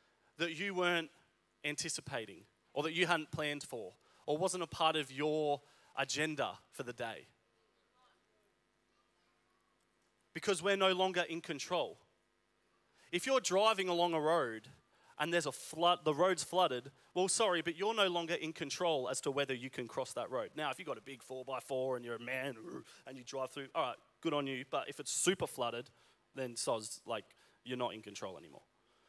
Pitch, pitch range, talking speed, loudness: 150 Hz, 130-175 Hz, 185 wpm, -37 LUFS